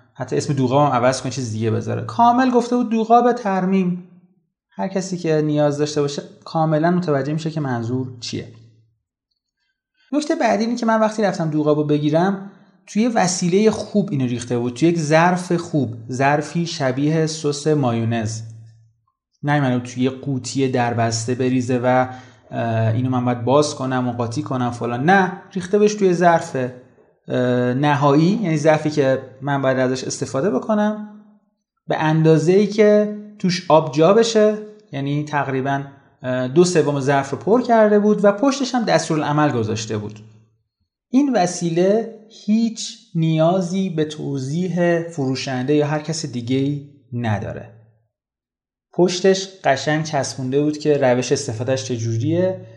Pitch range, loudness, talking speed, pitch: 130-190 Hz, -19 LUFS, 145 wpm, 150 Hz